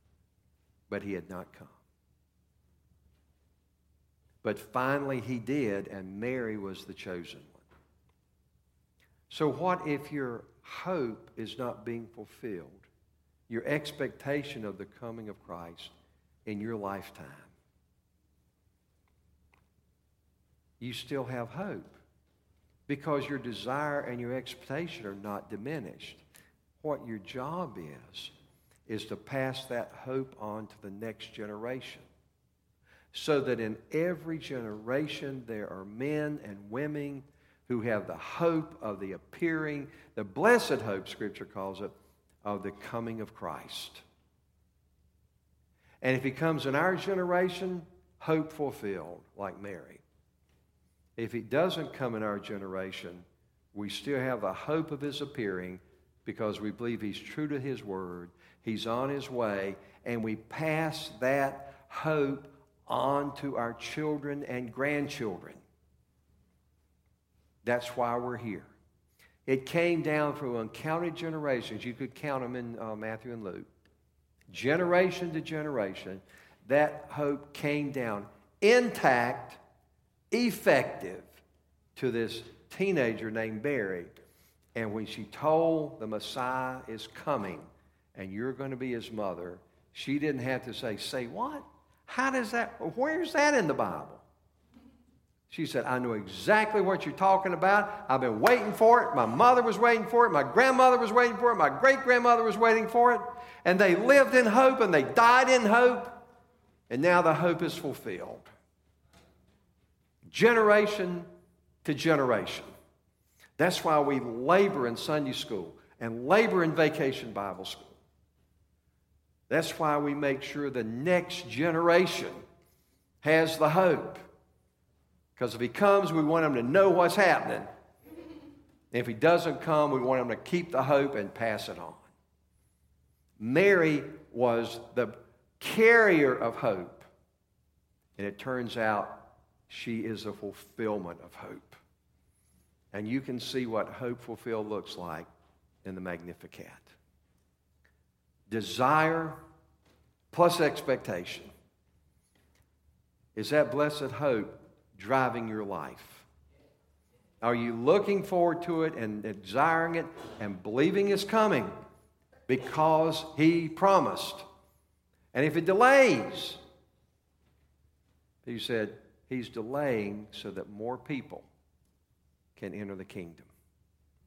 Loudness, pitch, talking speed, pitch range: -29 LUFS, 120 Hz, 130 wpm, 95-155 Hz